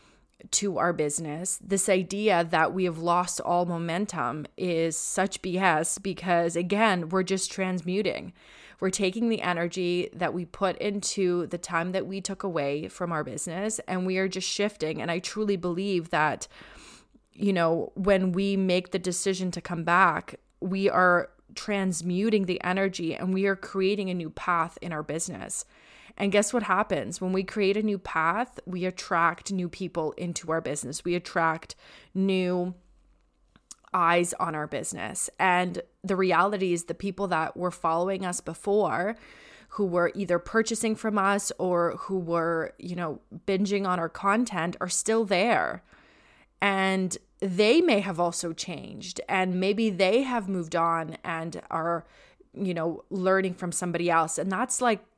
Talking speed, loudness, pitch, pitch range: 160 wpm, -27 LUFS, 185 Hz, 170-195 Hz